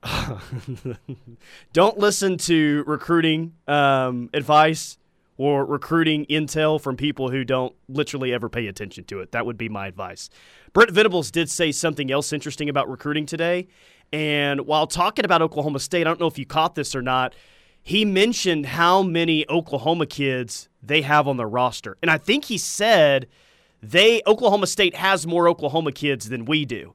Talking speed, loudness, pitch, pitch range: 165 wpm, -21 LUFS, 150 Hz, 135-170 Hz